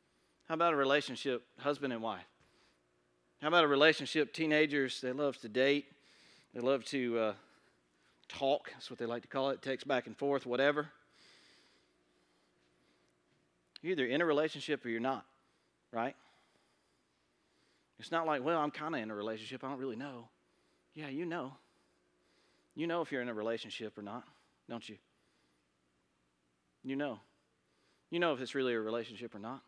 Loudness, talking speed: -35 LUFS, 165 wpm